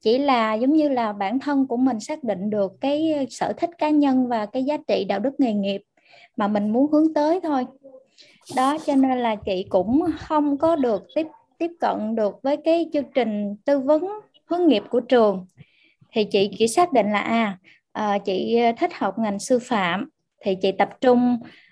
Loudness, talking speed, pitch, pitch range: -22 LUFS, 195 wpm, 250 Hz, 210-295 Hz